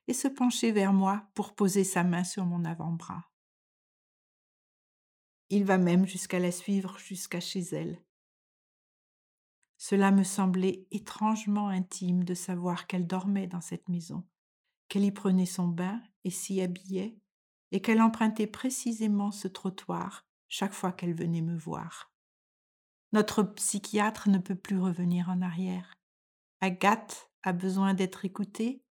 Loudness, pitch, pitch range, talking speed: -30 LUFS, 190 Hz, 180-205 Hz, 135 wpm